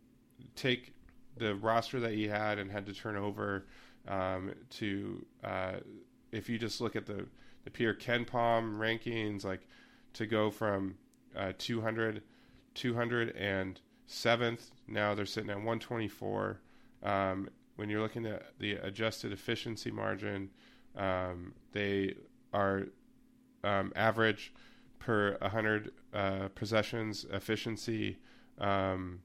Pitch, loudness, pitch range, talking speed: 105 Hz, -36 LUFS, 100-115 Hz, 130 wpm